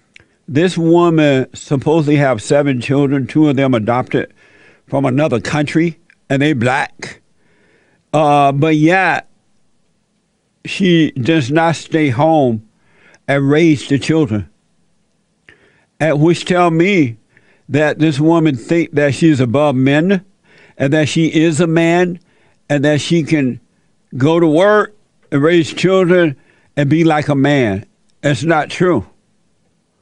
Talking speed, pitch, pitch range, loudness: 130 wpm, 155 Hz, 140-170 Hz, -14 LUFS